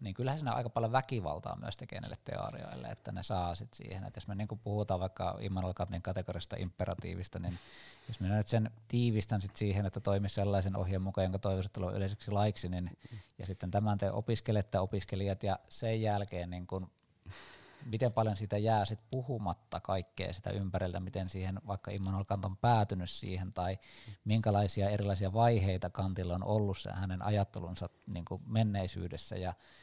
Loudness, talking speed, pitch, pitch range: -36 LUFS, 170 wpm, 100 Hz, 95-110 Hz